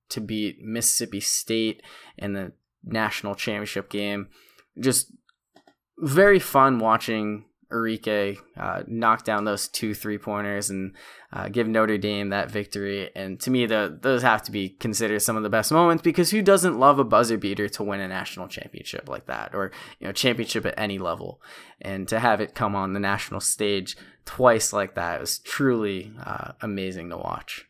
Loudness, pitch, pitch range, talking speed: -24 LUFS, 105 Hz, 100-115 Hz, 175 wpm